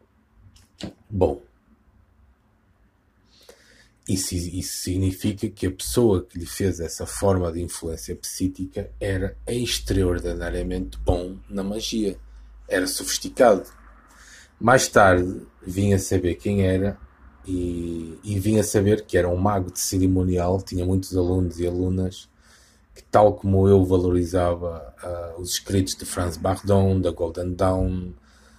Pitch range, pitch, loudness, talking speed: 90-100 Hz, 95 Hz, -23 LUFS, 125 wpm